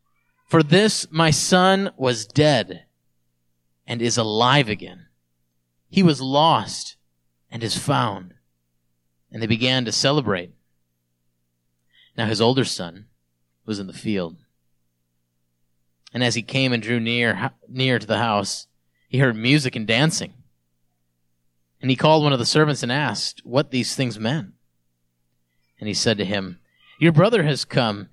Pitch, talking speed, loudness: 100 Hz, 145 wpm, -20 LUFS